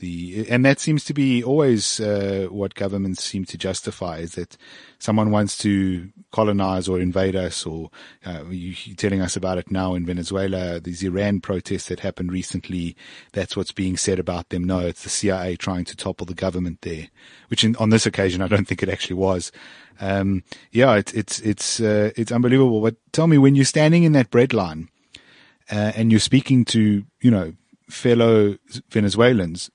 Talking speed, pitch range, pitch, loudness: 185 wpm, 90-110 Hz, 95 Hz, -21 LUFS